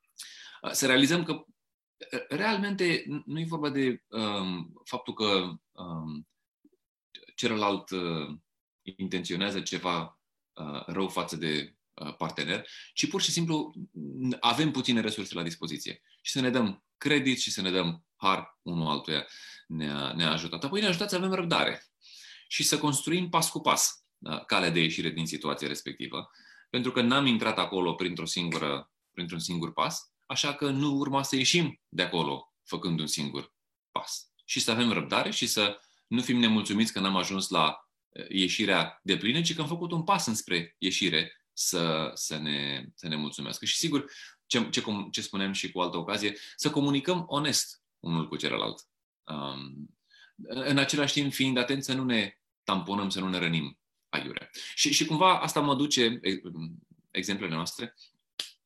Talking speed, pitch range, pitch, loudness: 155 wpm, 85-140 Hz, 100 Hz, -29 LUFS